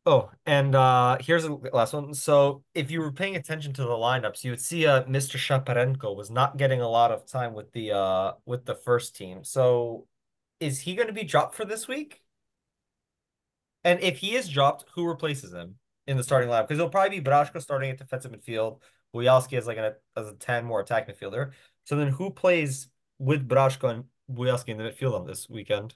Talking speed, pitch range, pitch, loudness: 215 wpm, 120-155 Hz, 135 Hz, -26 LUFS